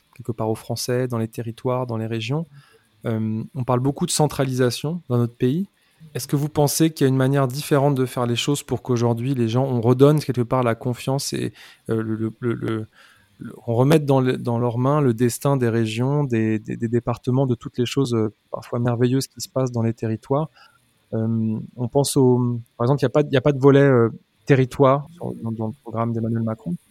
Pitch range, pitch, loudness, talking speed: 115-140 Hz, 125 Hz, -21 LUFS, 215 wpm